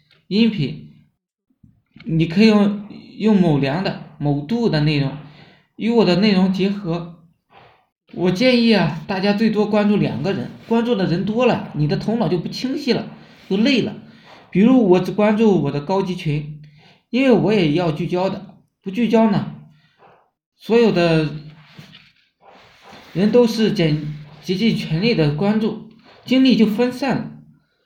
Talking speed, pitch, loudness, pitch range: 205 characters per minute, 195 Hz, -18 LUFS, 170-220 Hz